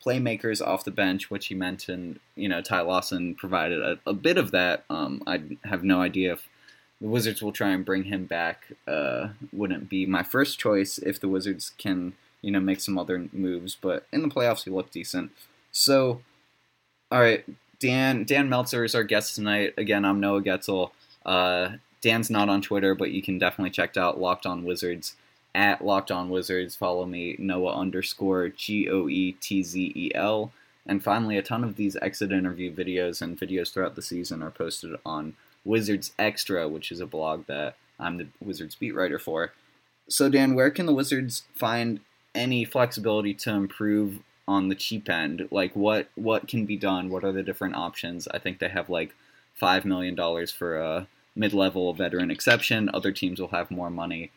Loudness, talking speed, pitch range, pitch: -27 LUFS, 180 wpm, 90-110 Hz, 95 Hz